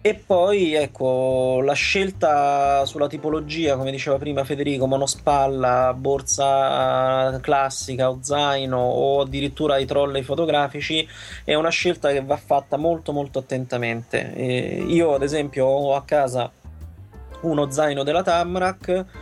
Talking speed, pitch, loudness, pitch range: 130 wpm, 140 Hz, -21 LUFS, 130-155 Hz